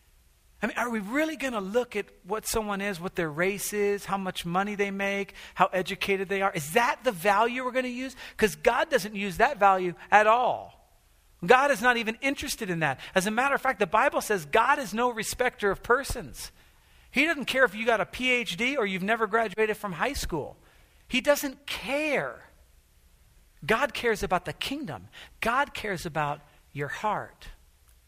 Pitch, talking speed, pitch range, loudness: 210 Hz, 190 wpm, 185-250 Hz, -27 LUFS